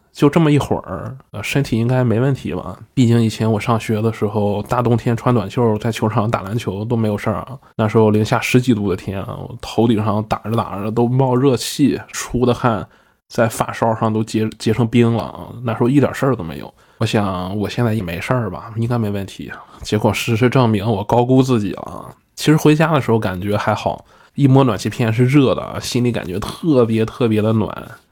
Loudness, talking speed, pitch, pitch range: -17 LUFS, 315 characters per minute, 115 Hz, 105-125 Hz